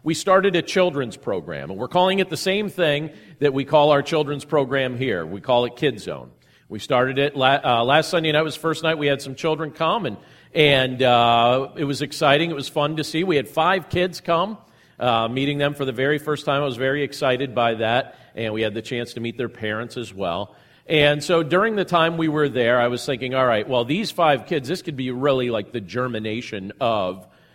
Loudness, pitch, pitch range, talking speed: -21 LUFS, 140 Hz, 120-155 Hz, 230 wpm